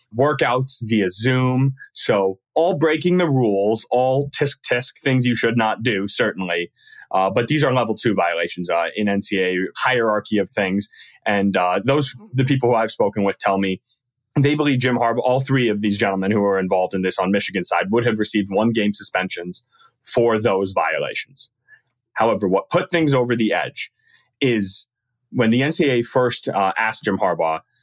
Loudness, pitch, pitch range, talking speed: -20 LUFS, 115 Hz, 100-130 Hz, 180 wpm